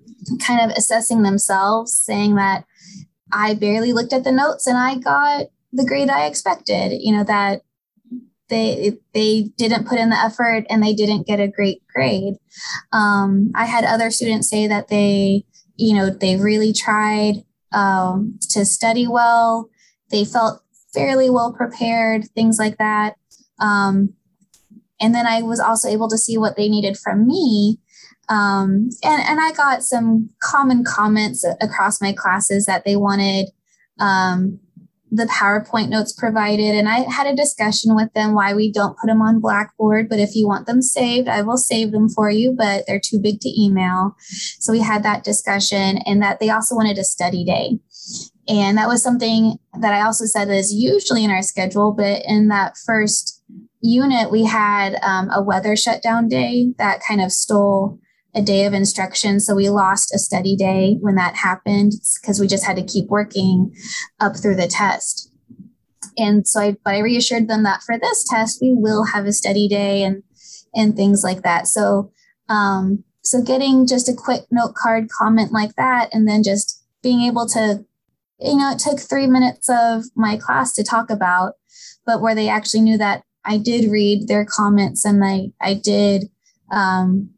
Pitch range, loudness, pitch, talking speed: 200-230 Hz, -17 LUFS, 215 Hz, 180 wpm